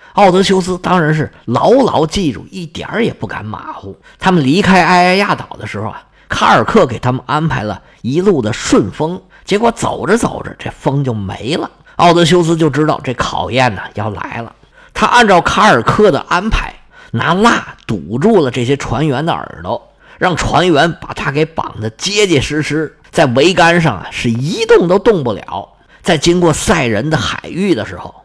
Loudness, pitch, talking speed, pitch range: -13 LUFS, 155 Hz, 270 characters per minute, 125-180 Hz